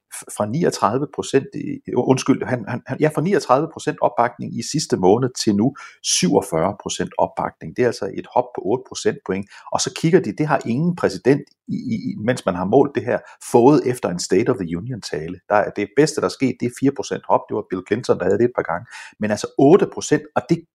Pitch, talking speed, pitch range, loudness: 130 Hz, 230 wpm, 105-150 Hz, -20 LUFS